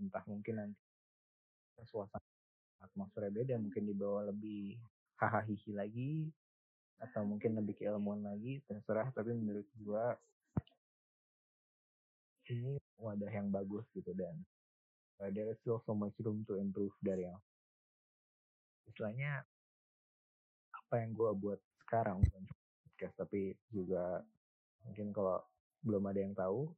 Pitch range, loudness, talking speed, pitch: 95-110 Hz, -42 LUFS, 120 wpm, 105 Hz